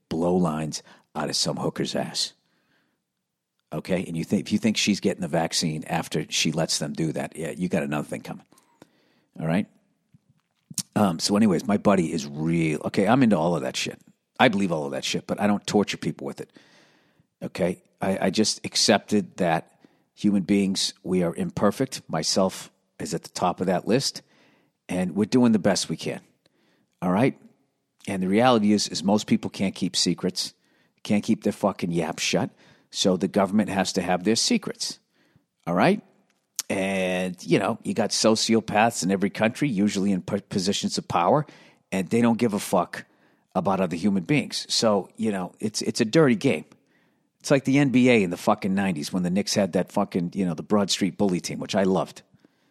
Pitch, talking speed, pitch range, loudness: 100 Hz, 190 wpm, 95-110 Hz, -24 LUFS